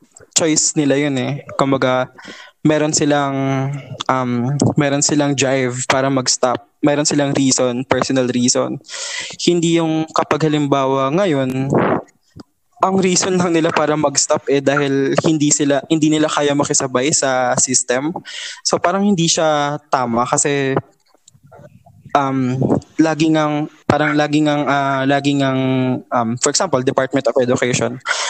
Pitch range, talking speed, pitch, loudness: 130-155 Hz, 130 wpm, 140 Hz, -16 LUFS